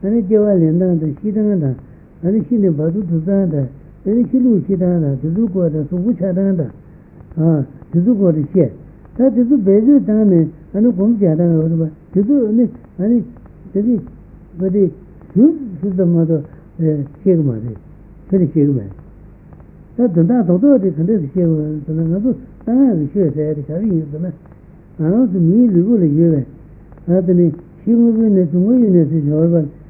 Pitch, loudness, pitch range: 180 Hz, -15 LUFS, 160-215 Hz